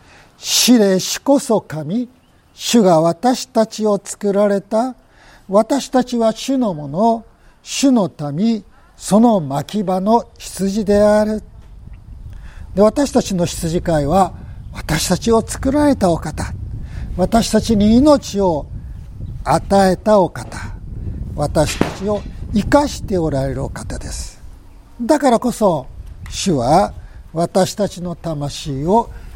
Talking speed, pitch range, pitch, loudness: 195 characters per minute, 145-225 Hz, 195 Hz, -16 LUFS